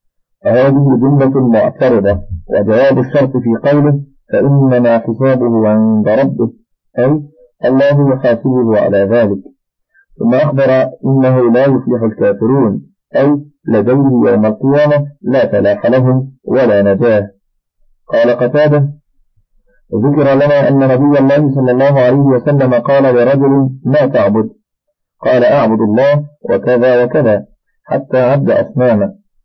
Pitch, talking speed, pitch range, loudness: 130 Hz, 110 wpm, 120-140 Hz, -11 LUFS